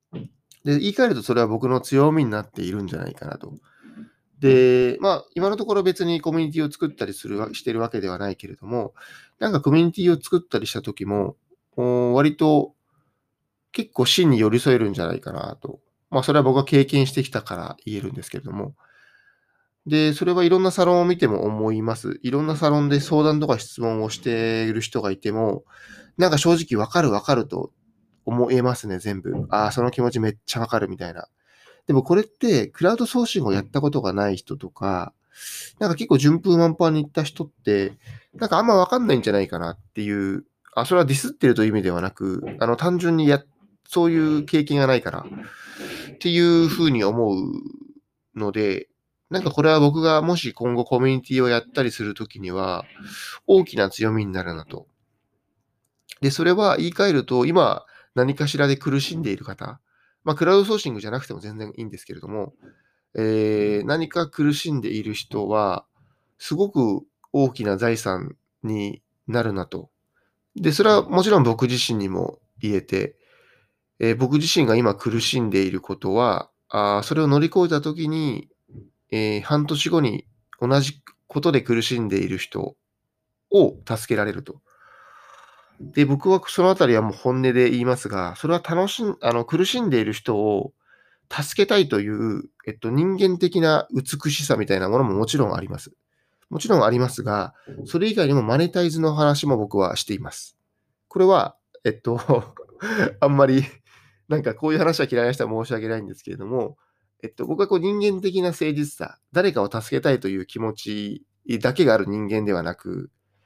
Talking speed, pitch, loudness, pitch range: 355 characters per minute, 135 Hz, -21 LUFS, 110-165 Hz